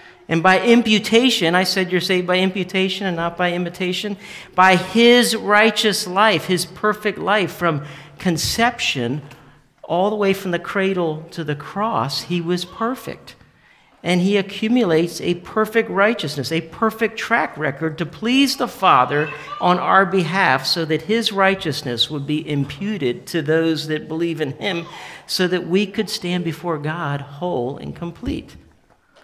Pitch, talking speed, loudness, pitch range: 180 Hz, 150 wpm, -19 LUFS, 160-205 Hz